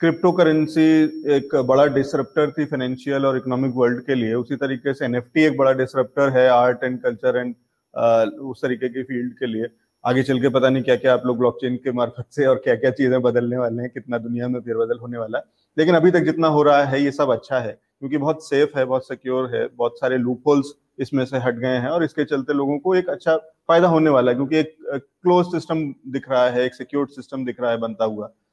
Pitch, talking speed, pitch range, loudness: 130 Hz, 230 wpm, 125-150 Hz, -20 LUFS